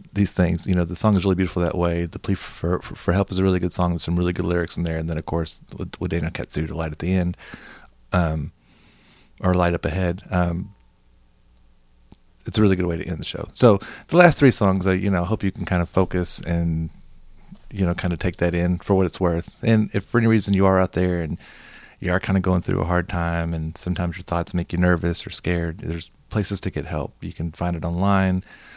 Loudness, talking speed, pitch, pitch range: -22 LUFS, 255 wpm, 90 Hz, 85-95 Hz